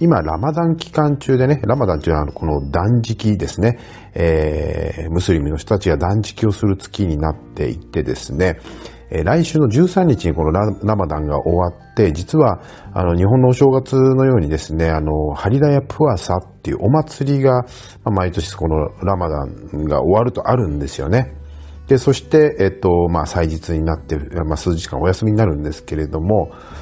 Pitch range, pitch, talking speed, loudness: 80-125 Hz, 95 Hz, 360 characters per minute, -17 LUFS